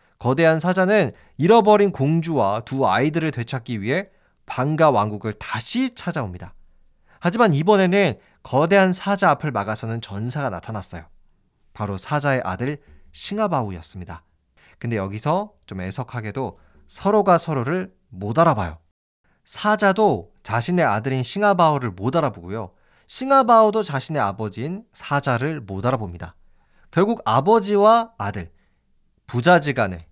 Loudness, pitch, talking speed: -20 LUFS, 130 Hz, 305 characters per minute